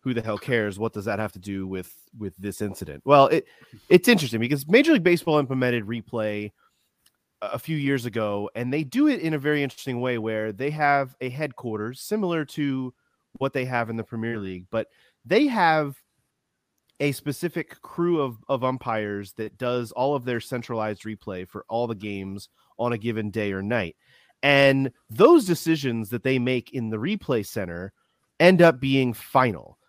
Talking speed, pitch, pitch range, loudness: 185 wpm, 120 Hz, 110-140 Hz, -24 LUFS